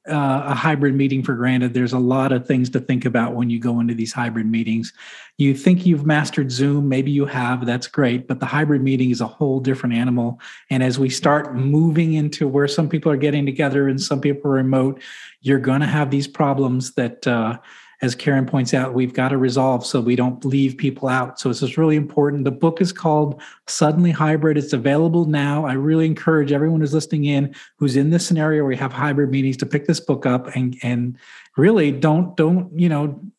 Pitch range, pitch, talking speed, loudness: 130-150 Hz, 140 Hz, 215 wpm, -19 LUFS